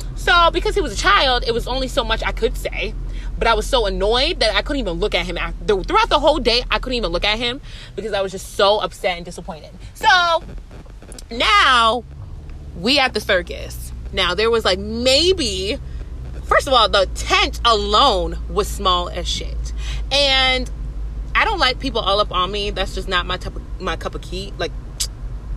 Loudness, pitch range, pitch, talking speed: -18 LUFS, 175-260 Hz, 210 Hz, 200 wpm